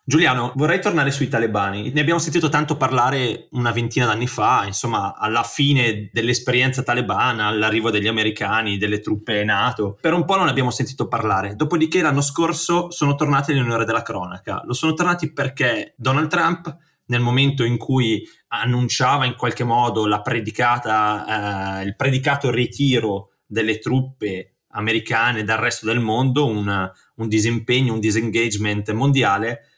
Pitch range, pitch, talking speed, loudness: 110-140 Hz, 120 Hz, 145 wpm, -20 LUFS